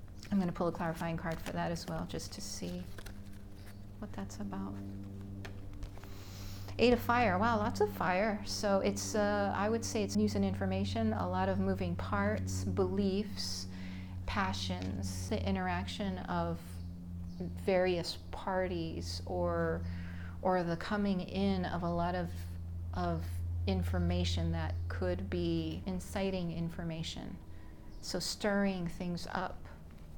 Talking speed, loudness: 130 wpm, -35 LUFS